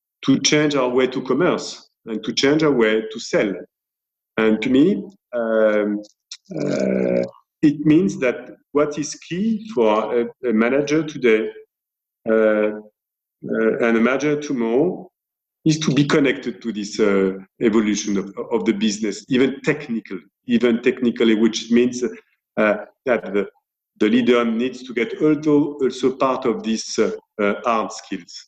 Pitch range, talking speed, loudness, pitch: 110-145 Hz, 145 wpm, -20 LUFS, 120 Hz